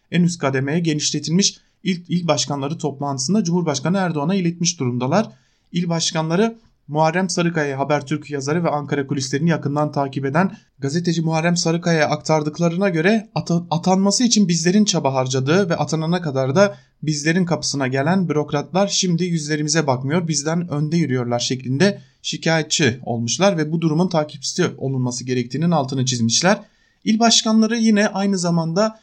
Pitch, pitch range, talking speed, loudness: 160 Hz, 145-180 Hz, 130 wpm, -19 LUFS